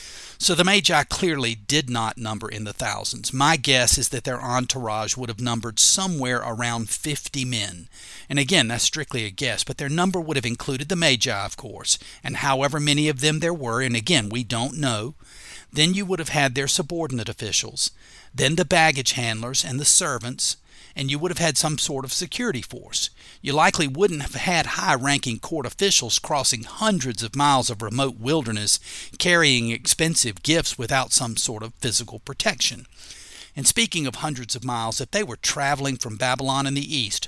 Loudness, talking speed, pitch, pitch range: -22 LUFS, 185 wpm, 135 Hz, 120-155 Hz